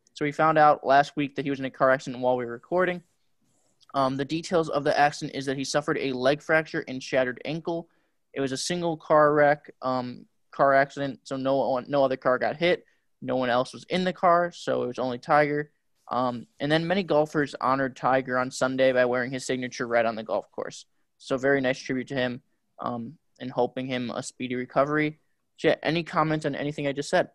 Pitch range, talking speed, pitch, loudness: 130-150 Hz, 215 wpm, 135 Hz, -26 LUFS